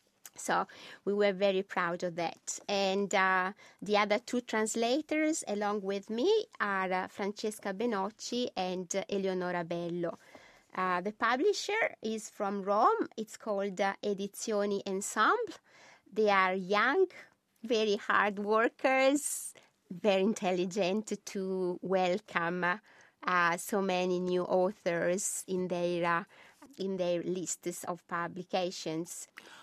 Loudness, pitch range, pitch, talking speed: -32 LUFS, 180-220 Hz, 200 Hz, 115 wpm